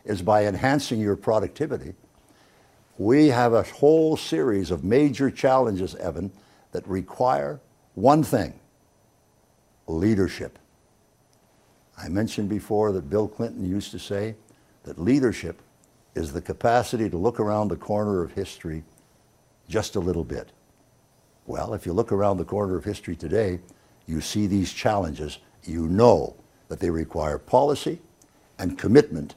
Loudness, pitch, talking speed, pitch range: -24 LUFS, 105 Hz, 135 wpm, 90-115 Hz